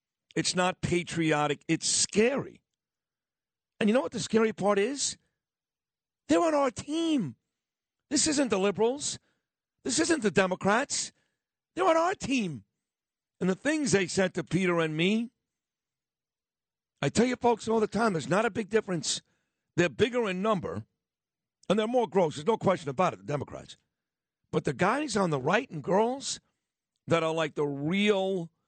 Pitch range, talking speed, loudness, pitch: 165-230 Hz, 165 wpm, -28 LUFS, 200 Hz